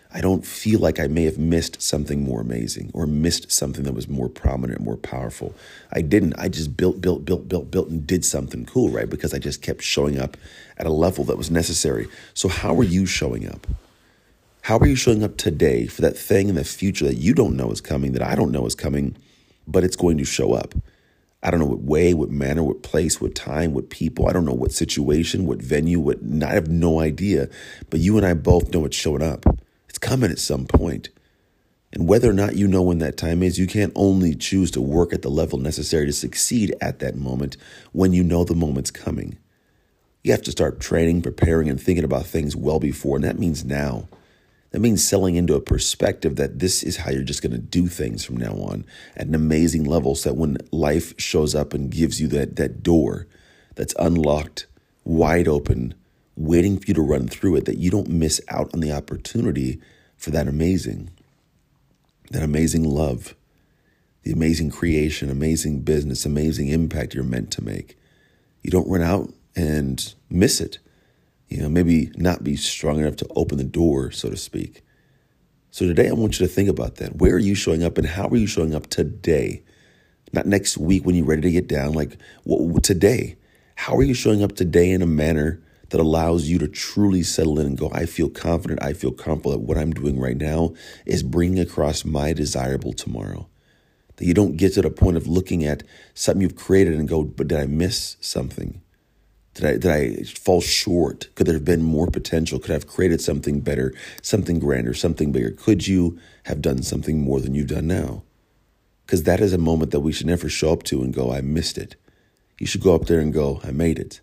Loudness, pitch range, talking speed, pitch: -21 LUFS, 75-90 Hz, 215 wpm, 80 Hz